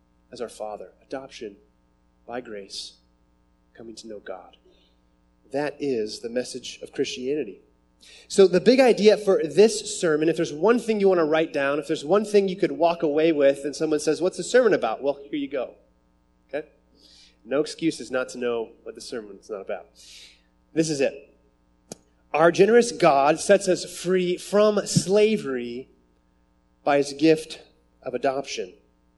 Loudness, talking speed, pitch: -22 LUFS, 165 wpm, 140 Hz